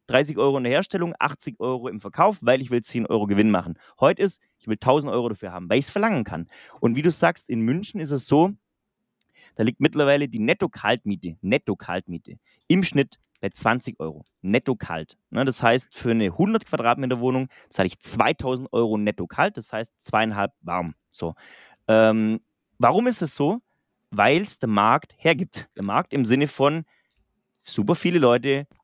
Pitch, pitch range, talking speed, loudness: 130 Hz, 110-155 Hz, 180 wpm, -23 LUFS